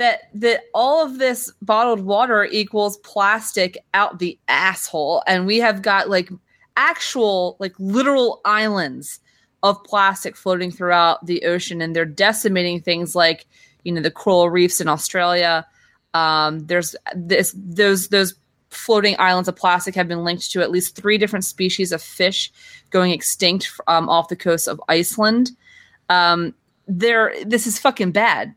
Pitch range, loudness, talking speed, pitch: 175-210 Hz, -18 LUFS, 155 wpm, 185 Hz